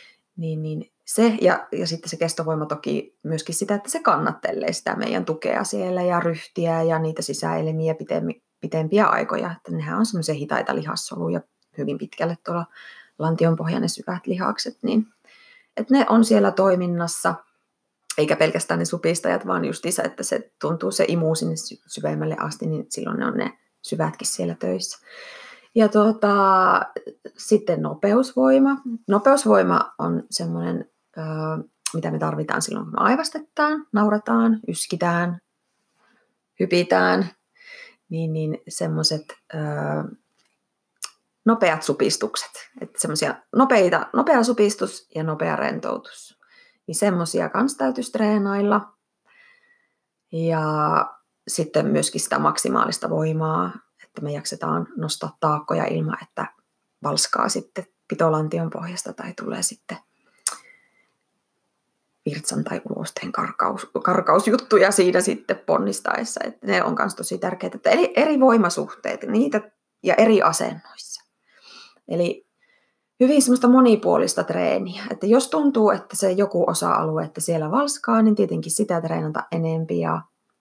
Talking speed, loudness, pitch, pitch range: 120 wpm, -22 LUFS, 185 Hz, 160-240 Hz